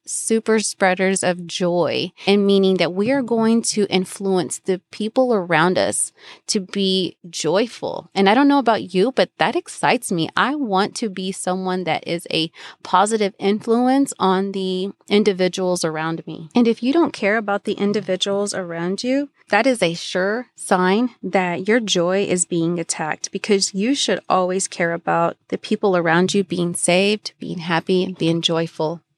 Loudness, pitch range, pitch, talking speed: -19 LUFS, 175-215 Hz, 190 Hz, 170 wpm